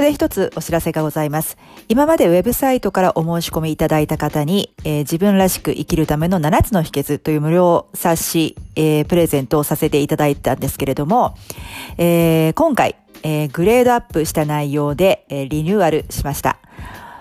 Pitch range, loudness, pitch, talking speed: 150-185 Hz, -17 LUFS, 160 Hz, 340 characters per minute